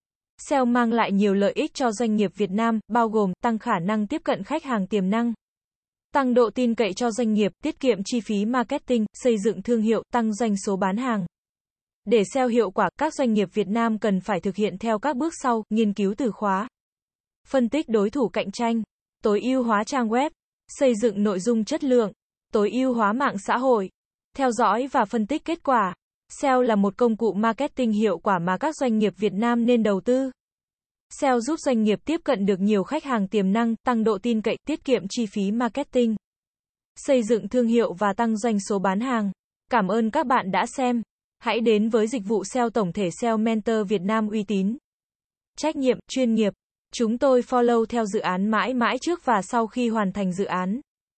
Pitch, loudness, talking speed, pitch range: 230 Hz, -23 LUFS, 215 wpm, 210-250 Hz